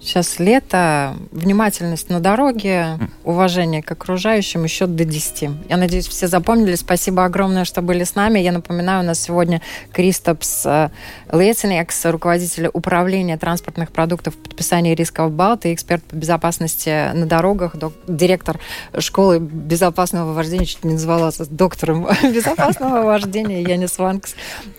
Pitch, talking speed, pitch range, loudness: 175 Hz, 135 wpm, 165-185 Hz, -17 LUFS